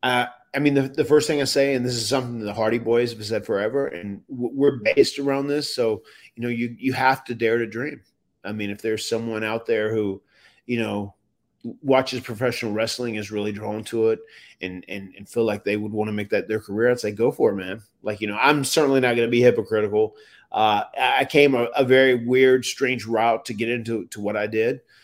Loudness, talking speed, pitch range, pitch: -22 LUFS, 235 wpm, 110-130 Hz, 120 Hz